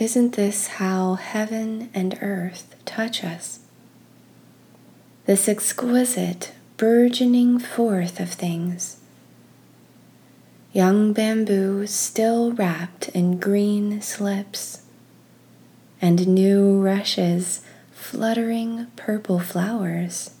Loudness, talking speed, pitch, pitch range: -22 LUFS, 80 wpm, 200 Hz, 185-225 Hz